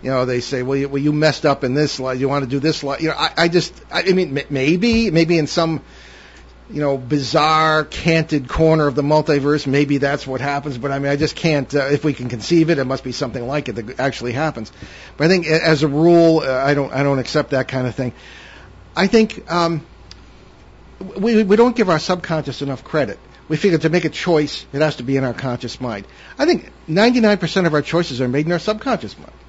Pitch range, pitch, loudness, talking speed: 135-165 Hz, 150 Hz, -18 LUFS, 240 wpm